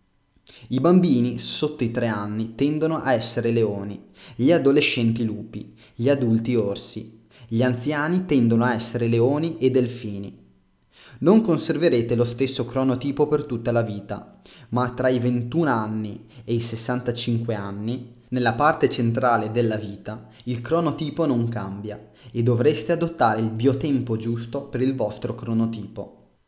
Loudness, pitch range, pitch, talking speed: -23 LUFS, 110-135 Hz, 120 Hz, 140 wpm